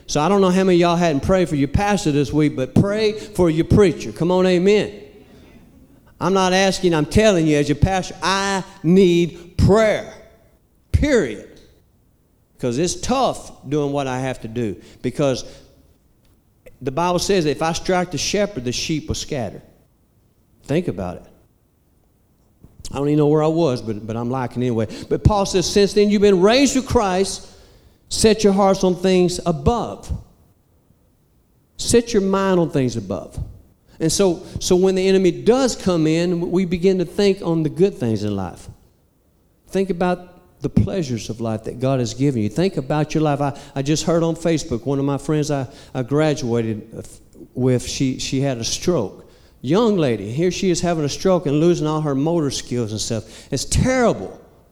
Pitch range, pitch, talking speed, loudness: 125-185 Hz, 155 Hz, 180 wpm, -19 LUFS